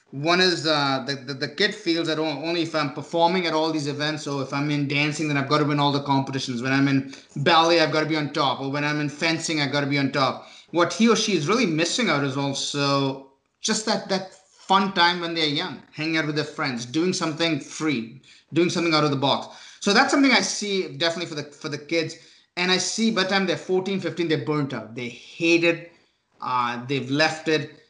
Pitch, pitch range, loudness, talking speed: 155 Hz, 140-170 Hz, -23 LUFS, 235 wpm